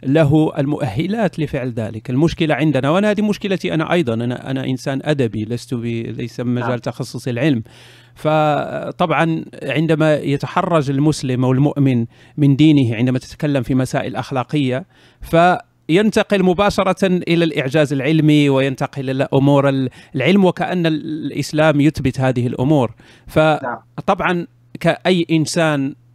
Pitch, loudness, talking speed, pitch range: 145 Hz, -17 LUFS, 115 wpm, 130-160 Hz